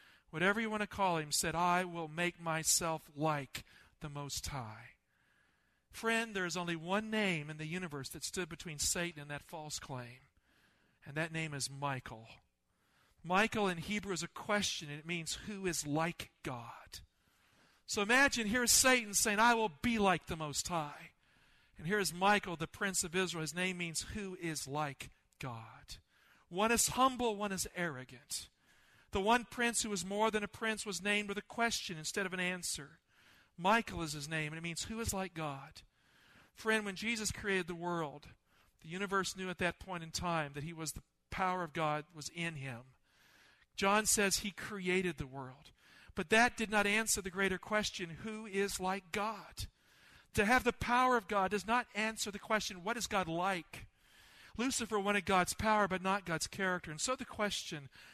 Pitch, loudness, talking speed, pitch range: 185 Hz, -35 LUFS, 185 wpm, 160-210 Hz